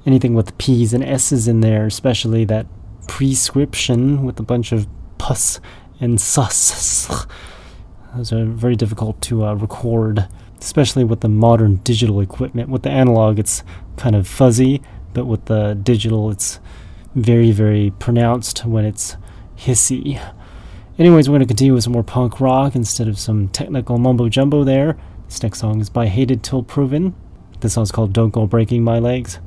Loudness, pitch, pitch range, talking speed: -16 LUFS, 115 Hz, 105-125 Hz, 165 wpm